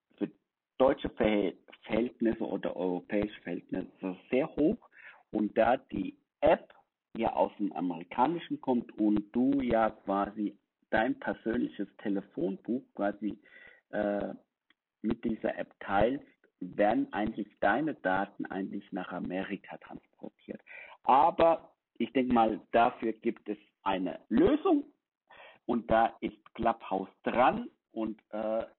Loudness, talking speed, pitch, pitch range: -31 LUFS, 110 wpm, 110 Hz, 105-130 Hz